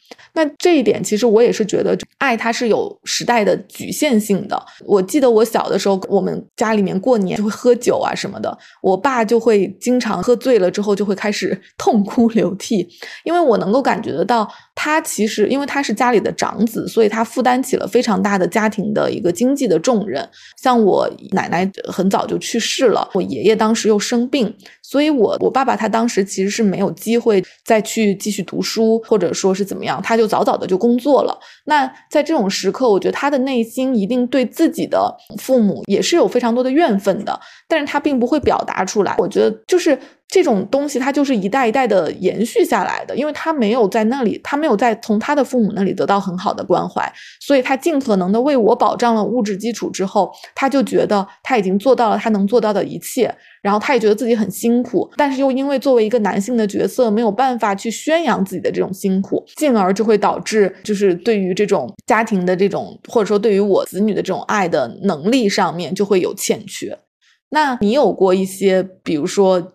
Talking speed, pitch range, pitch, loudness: 320 characters per minute, 200-260 Hz, 225 Hz, -17 LUFS